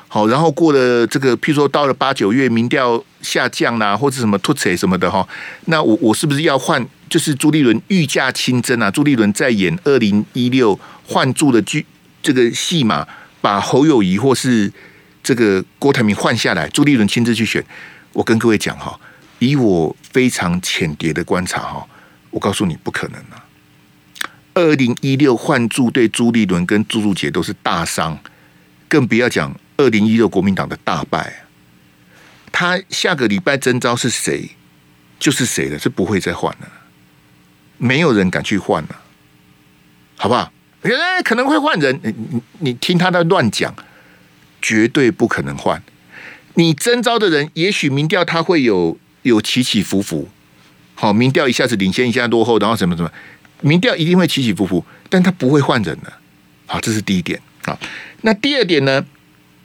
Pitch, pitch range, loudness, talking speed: 125 Hz, 100-150 Hz, -15 LUFS, 260 characters per minute